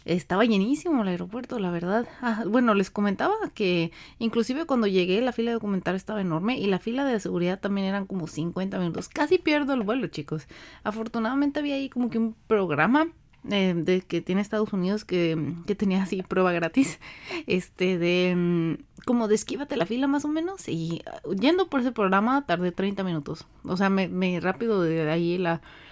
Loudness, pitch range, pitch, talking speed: -26 LUFS, 180-240 Hz, 195 Hz, 190 wpm